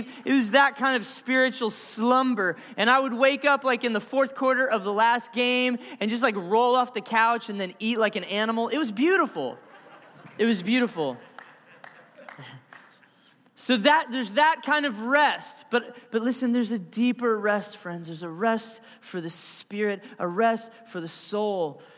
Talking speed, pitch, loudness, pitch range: 180 wpm, 235 Hz, -24 LUFS, 210-260 Hz